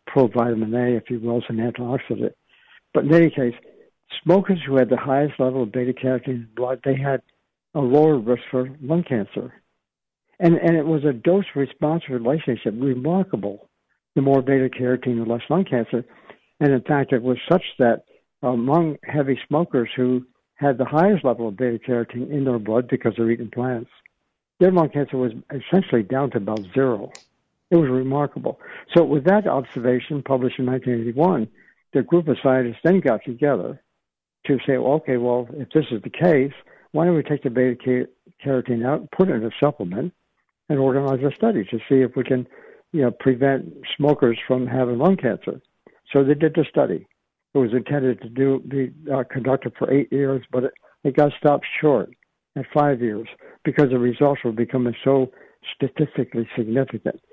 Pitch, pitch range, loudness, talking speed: 130 Hz, 125-145 Hz, -21 LUFS, 175 wpm